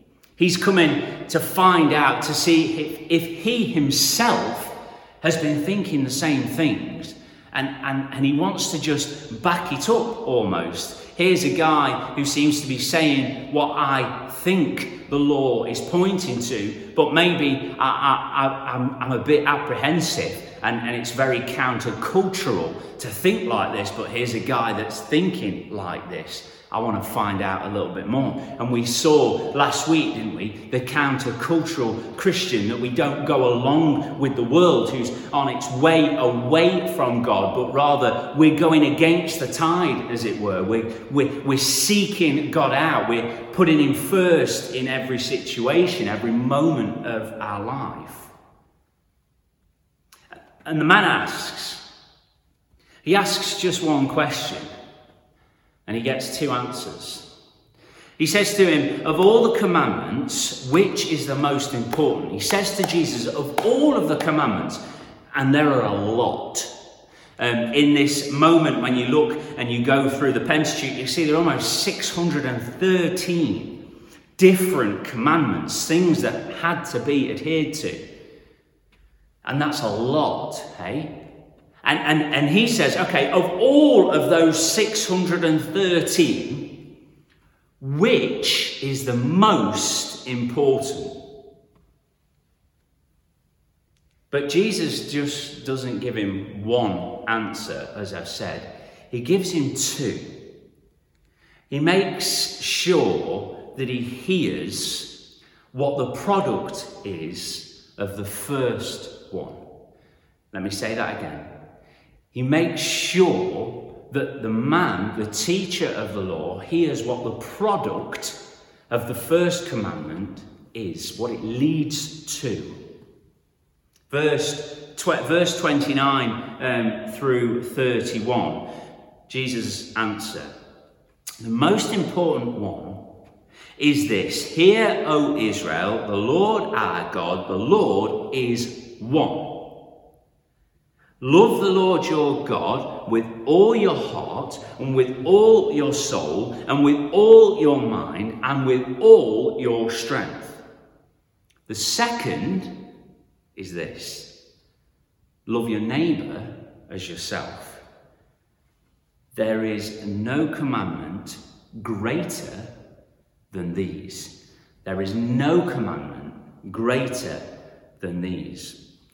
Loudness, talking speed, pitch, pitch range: -21 LUFS, 125 wpm, 140 Hz, 120-165 Hz